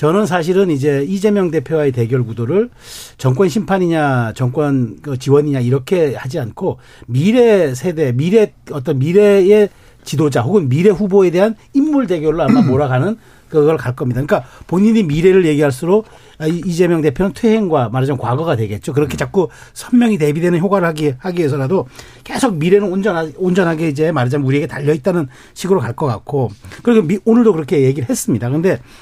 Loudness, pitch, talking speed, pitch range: -15 LUFS, 160 Hz, 385 characters per minute, 135-195 Hz